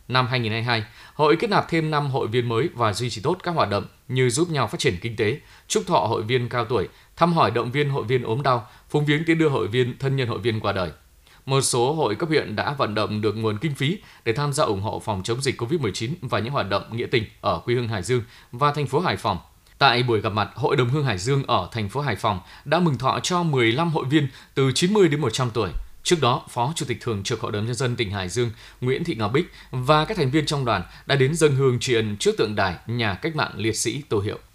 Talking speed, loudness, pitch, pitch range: 265 wpm, -23 LUFS, 125 Hz, 115-145 Hz